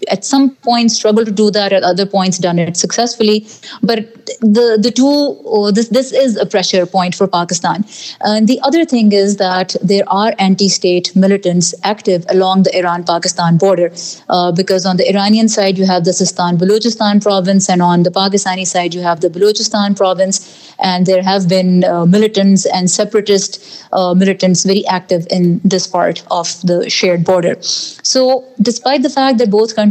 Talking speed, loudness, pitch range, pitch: 175 wpm, -12 LUFS, 180-215 Hz, 195 Hz